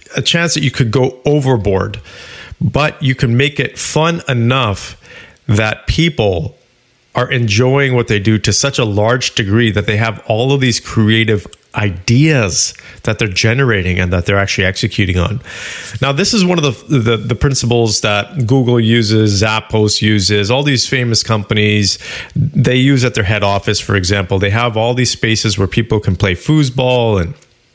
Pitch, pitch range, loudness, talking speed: 115 Hz, 105-130 Hz, -13 LUFS, 175 wpm